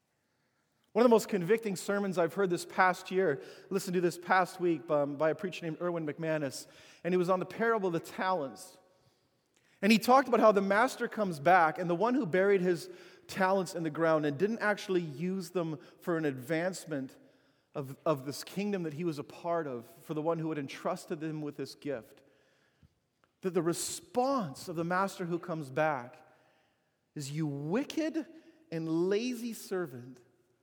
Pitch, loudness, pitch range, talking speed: 175 Hz, -32 LUFS, 155-195 Hz, 185 wpm